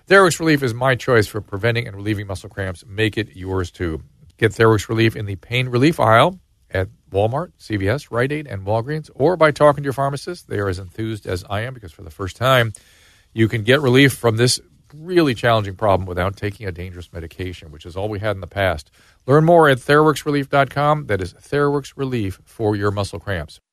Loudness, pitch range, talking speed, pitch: -19 LUFS, 95-135 Hz, 205 wpm, 110 Hz